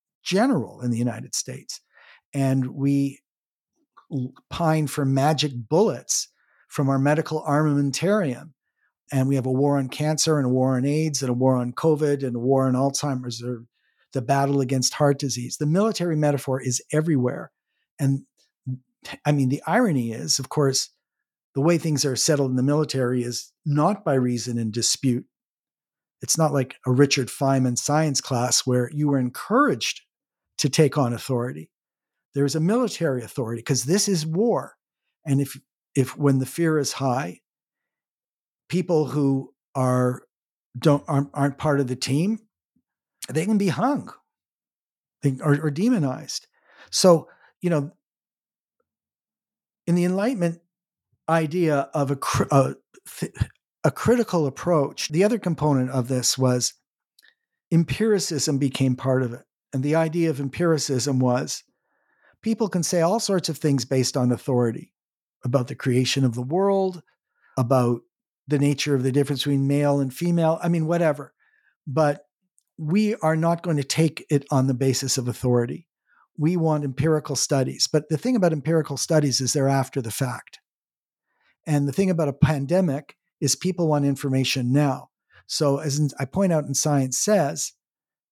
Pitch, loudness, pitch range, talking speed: 145 Hz, -23 LUFS, 130-160 Hz, 155 wpm